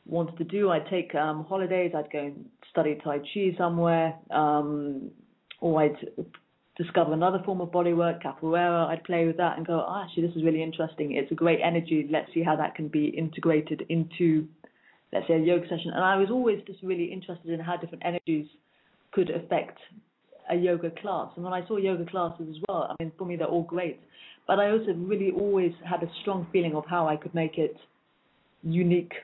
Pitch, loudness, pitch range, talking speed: 170 Hz, -28 LUFS, 160-185 Hz, 205 wpm